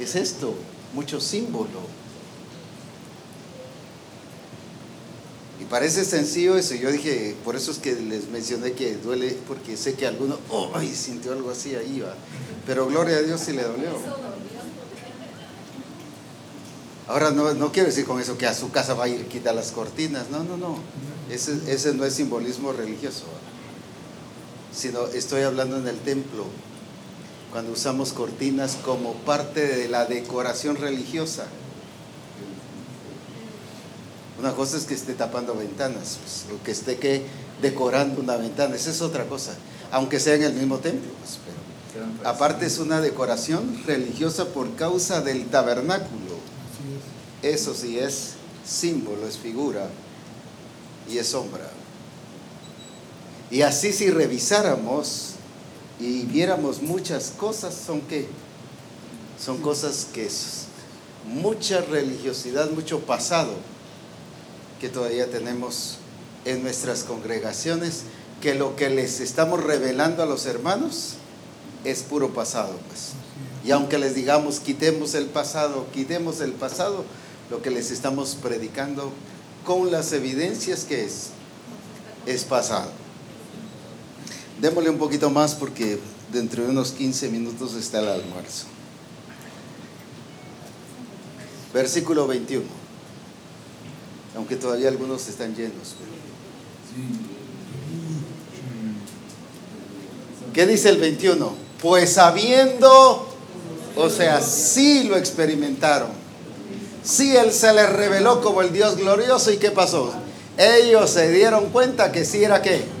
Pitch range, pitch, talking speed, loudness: 125-160 Hz, 140 Hz, 125 wpm, -22 LUFS